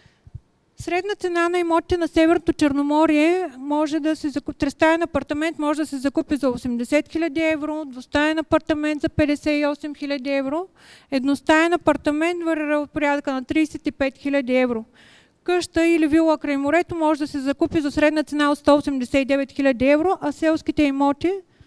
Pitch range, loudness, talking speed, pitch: 285-325 Hz, -21 LUFS, 150 wpm, 305 Hz